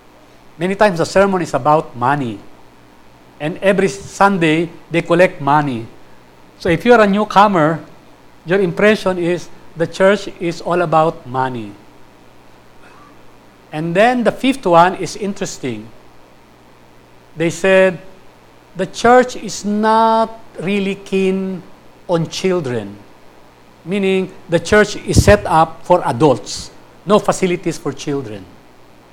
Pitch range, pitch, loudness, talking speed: 130-190 Hz, 170 Hz, -15 LUFS, 115 wpm